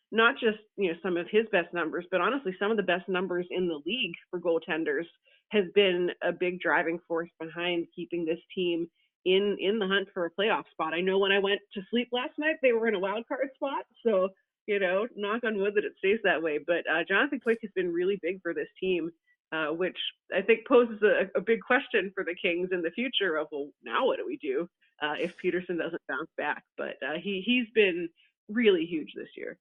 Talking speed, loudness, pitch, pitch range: 230 wpm, -29 LUFS, 195 Hz, 175-235 Hz